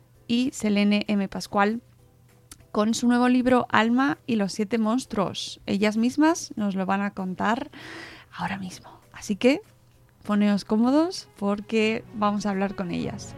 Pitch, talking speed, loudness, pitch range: 215 Hz, 145 wpm, -25 LUFS, 200-245 Hz